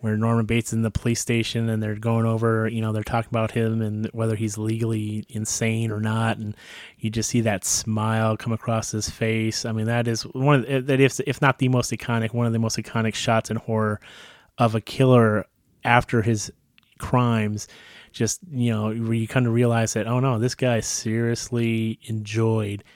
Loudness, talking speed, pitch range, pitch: -23 LUFS, 195 wpm, 110-120 Hz, 115 Hz